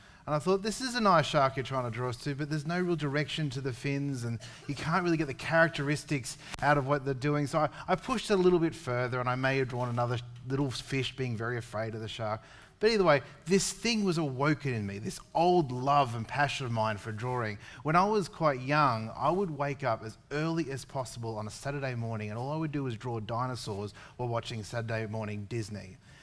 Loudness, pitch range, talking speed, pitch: -31 LUFS, 120-155 Hz, 240 wpm, 135 Hz